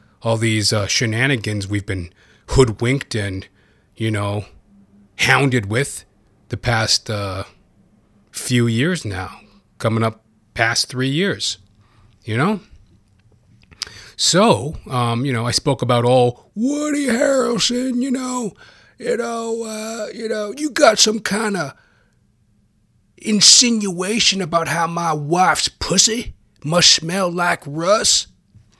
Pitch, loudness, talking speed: 120 Hz, -17 LUFS, 120 wpm